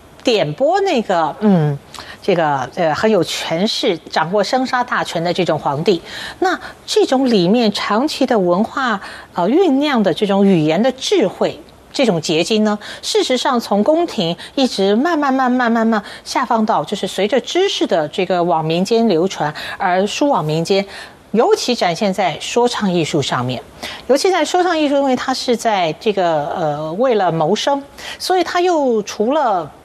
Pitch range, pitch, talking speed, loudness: 185-280 Hz, 225 Hz, 245 characters per minute, -16 LUFS